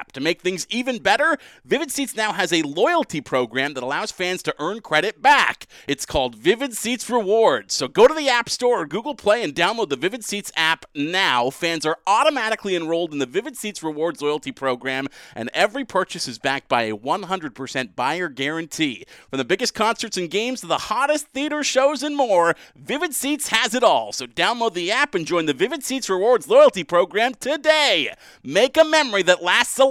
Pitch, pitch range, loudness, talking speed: 205 Hz, 160-270 Hz, -20 LUFS, 195 wpm